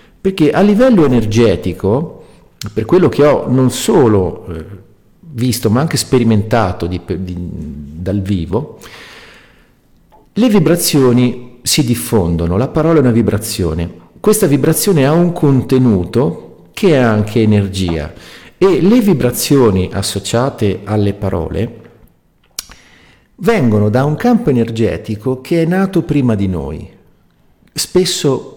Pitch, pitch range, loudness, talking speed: 115 Hz, 100-145 Hz, -13 LUFS, 115 wpm